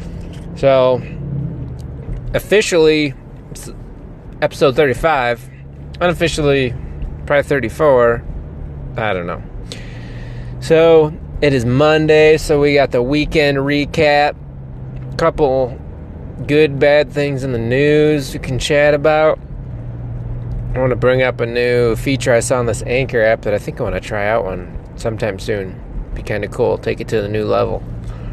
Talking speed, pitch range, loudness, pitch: 135 wpm, 120-150 Hz, -15 LUFS, 130 Hz